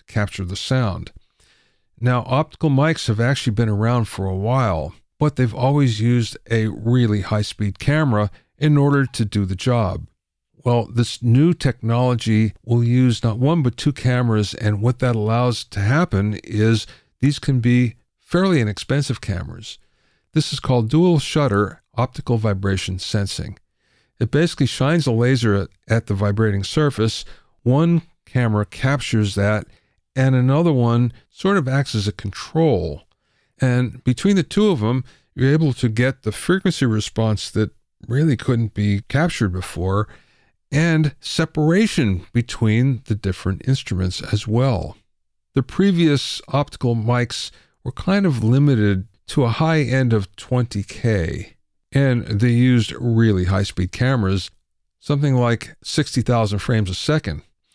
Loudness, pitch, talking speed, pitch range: -19 LUFS, 120 Hz, 140 wpm, 105-135 Hz